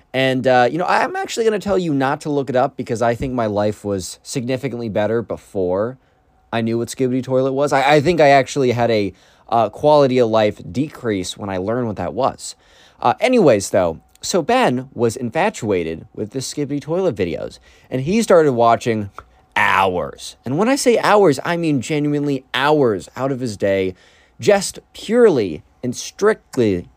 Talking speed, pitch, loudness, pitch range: 180 wpm, 130 Hz, -18 LUFS, 115-150 Hz